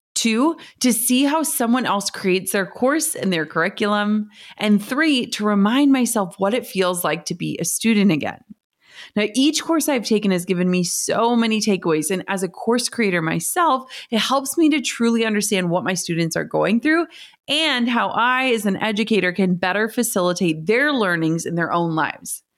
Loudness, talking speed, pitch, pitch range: -19 LUFS, 185 wpm, 215 Hz, 185-250 Hz